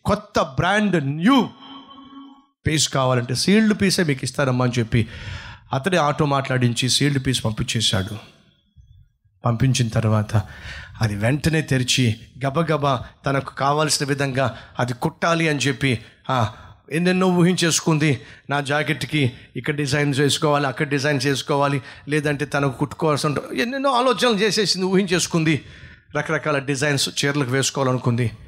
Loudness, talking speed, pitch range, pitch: -20 LUFS, 110 wpm, 125-160 Hz, 140 Hz